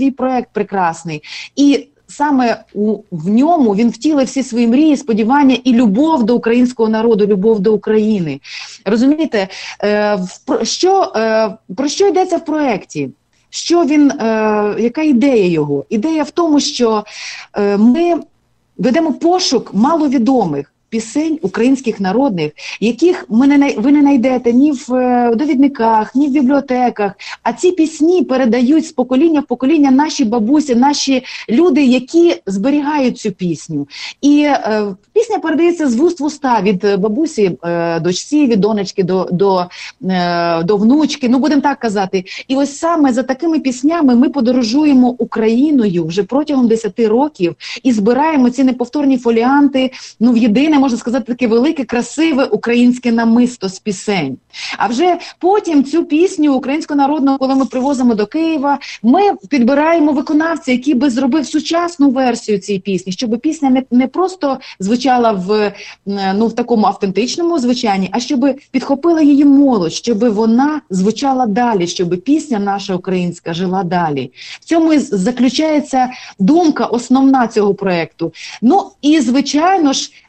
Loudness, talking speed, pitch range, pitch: -13 LUFS, 140 wpm, 215-290 Hz, 250 Hz